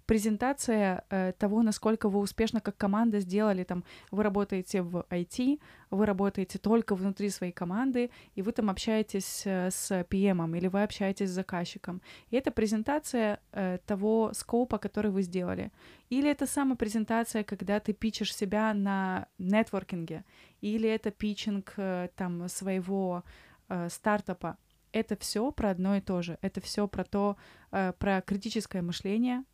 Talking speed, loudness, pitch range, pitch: 150 wpm, -31 LUFS, 190-220 Hz, 205 Hz